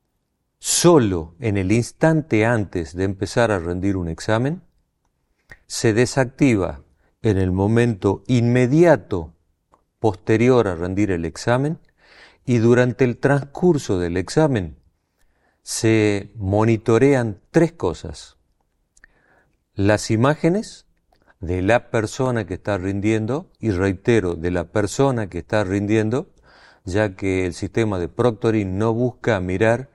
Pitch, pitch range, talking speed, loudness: 110 Hz, 95-125 Hz, 115 wpm, -20 LUFS